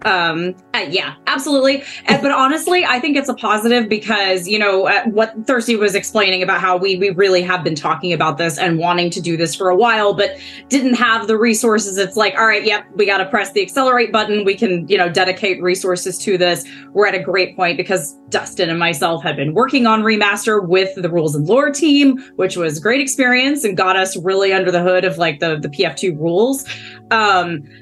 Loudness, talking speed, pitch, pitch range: -15 LUFS, 220 wpm, 195 Hz, 180-225 Hz